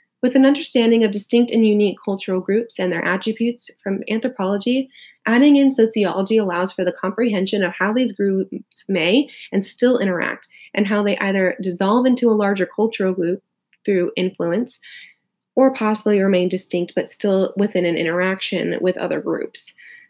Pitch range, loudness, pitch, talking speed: 185-235 Hz, -19 LUFS, 205 Hz, 160 wpm